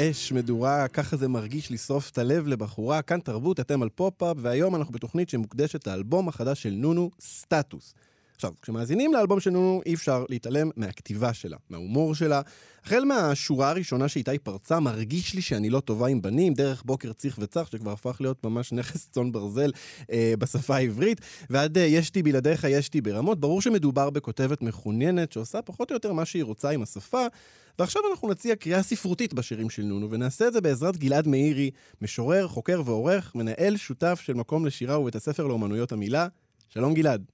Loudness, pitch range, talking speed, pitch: -27 LUFS, 120-170 Hz, 165 wpm, 140 Hz